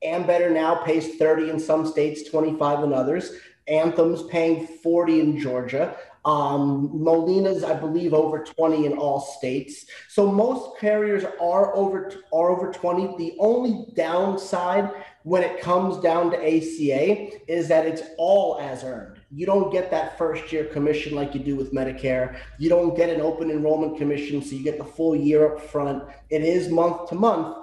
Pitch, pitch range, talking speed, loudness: 160 Hz, 150-180 Hz, 175 wpm, -23 LUFS